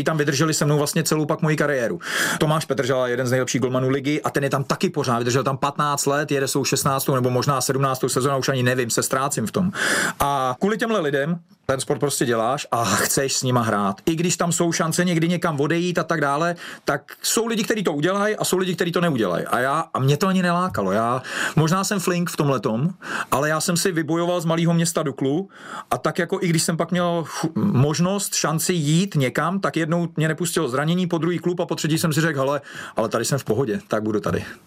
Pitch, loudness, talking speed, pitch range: 155 Hz, -21 LUFS, 230 wpm, 135-175 Hz